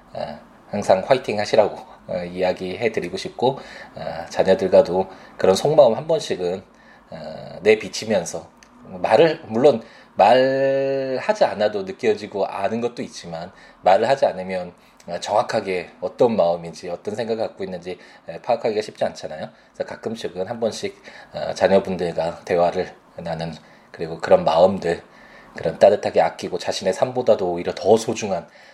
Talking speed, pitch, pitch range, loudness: 305 characters per minute, 95 Hz, 90-130 Hz, -21 LUFS